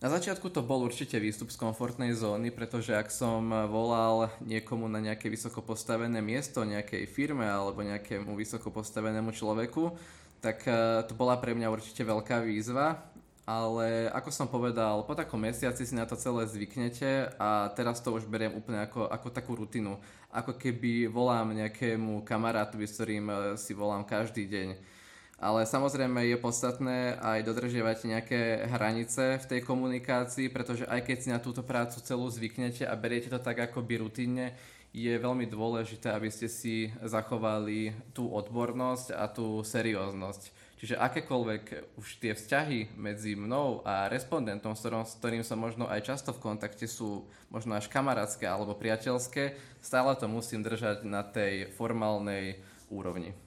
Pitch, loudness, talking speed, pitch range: 115 Hz, -33 LUFS, 150 wpm, 110-125 Hz